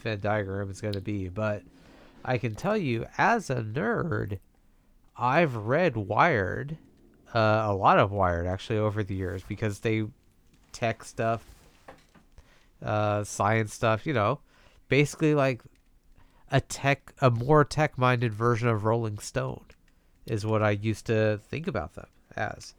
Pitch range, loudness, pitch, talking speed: 100-125 Hz, -27 LUFS, 110 Hz, 145 wpm